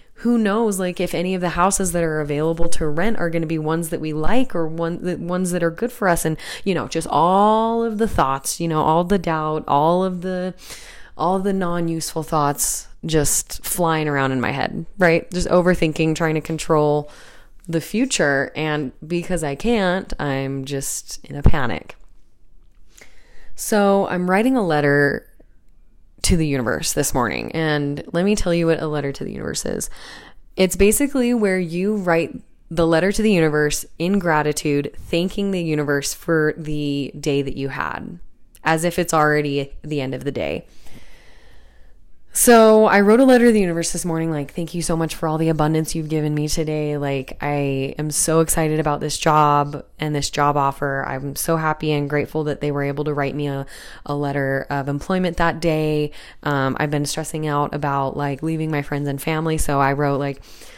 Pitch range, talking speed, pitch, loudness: 145-175 Hz, 195 wpm, 160 Hz, -20 LUFS